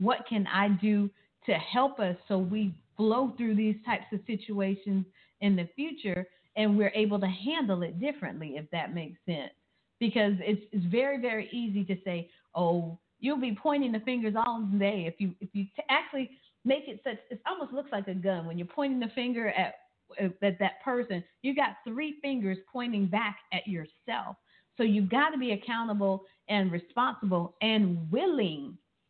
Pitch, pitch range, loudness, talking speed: 210 Hz, 190-245 Hz, -31 LUFS, 180 wpm